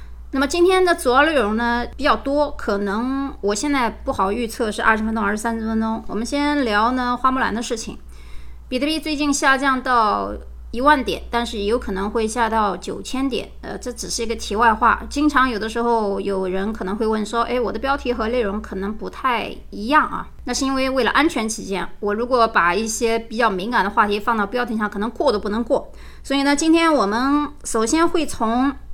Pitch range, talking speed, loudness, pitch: 215-270 Hz, 310 characters per minute, -20 LUFS, 235 Hz